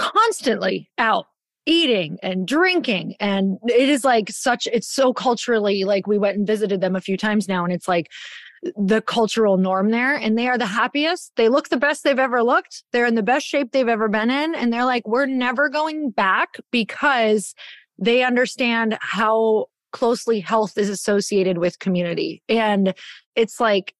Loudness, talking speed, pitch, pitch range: -20 LUFS, 180 wpm, 230 Hz, 205-255 Hz